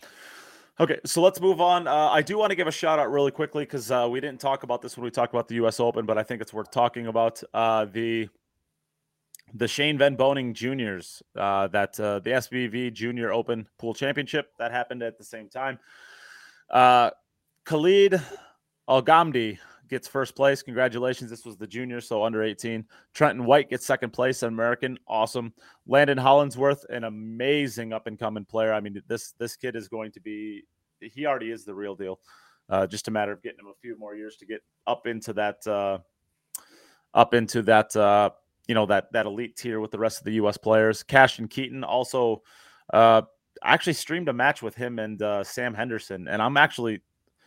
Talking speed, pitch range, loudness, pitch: 195 wpm, 110-135 Hz, -24 LUFS, 120 Hz